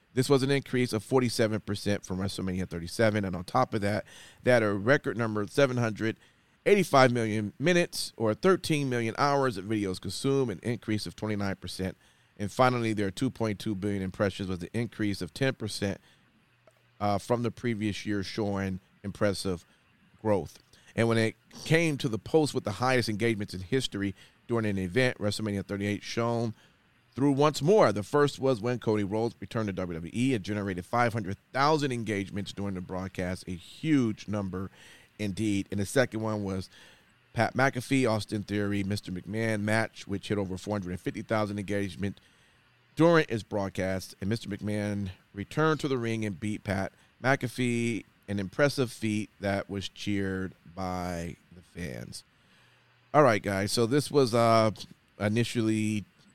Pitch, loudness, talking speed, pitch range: 105 Hz, -29 LUFS, 160 wpm, 100-125 Hz